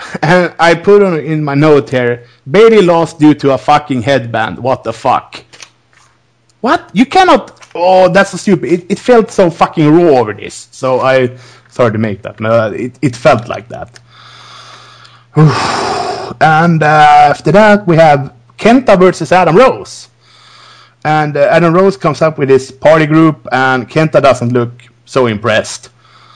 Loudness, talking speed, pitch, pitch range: -9 LUFS, 160 wpm, 150 Hz, 125-180 Hz